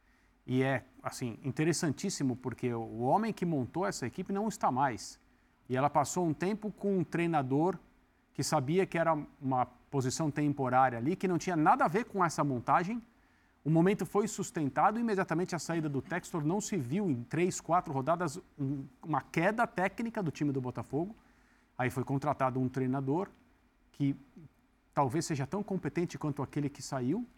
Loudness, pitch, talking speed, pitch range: -33 LUFS, 155 Hz, 170 wpm, 135-185 Hz